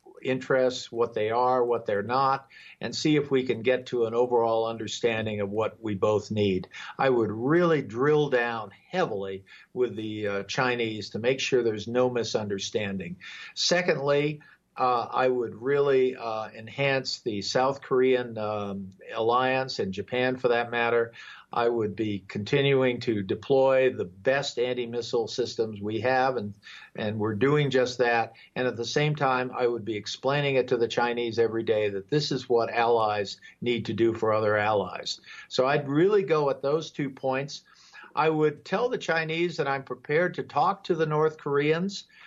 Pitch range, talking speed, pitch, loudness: 110-135 Hz, 175 wpm, 125 Hz, -27 LUFS